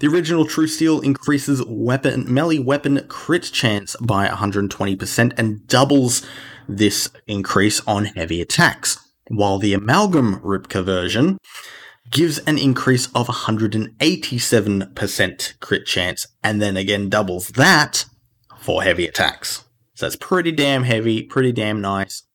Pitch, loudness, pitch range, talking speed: 120 Hz, -18 LUFS, 105-140 Hz, 125 wpm